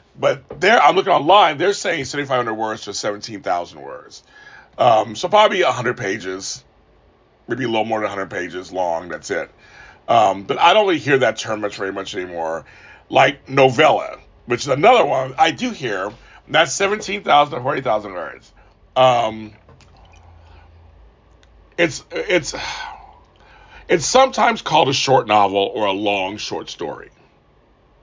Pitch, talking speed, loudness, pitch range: 110 Hz, 145 wpm, -18 LUFS, 95-135 Hz